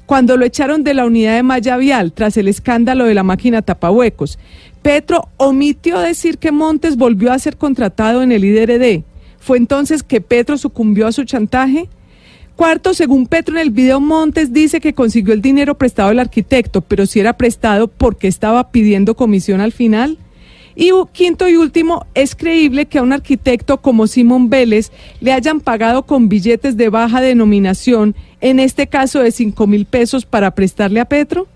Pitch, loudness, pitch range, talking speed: 255 Hz, -12 LUFS, 225-285 Hz, 180 wpm